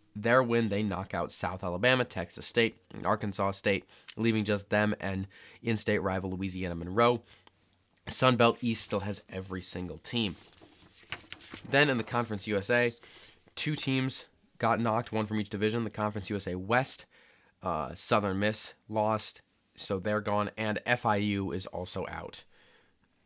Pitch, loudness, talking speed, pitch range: 105 Hz, -31 LUFS, 145 wpm, 95-115 Hz